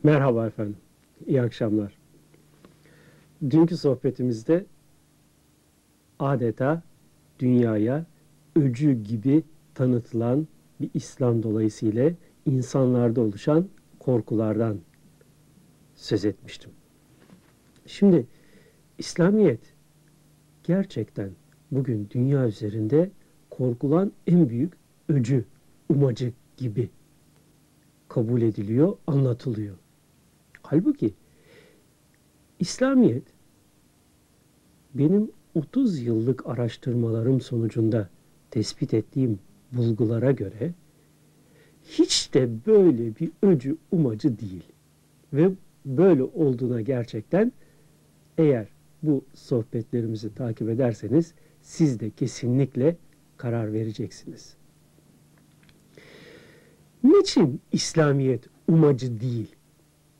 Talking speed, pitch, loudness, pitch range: 70 wpm, 130 Hz, -24 LUFS, 115-155 Hz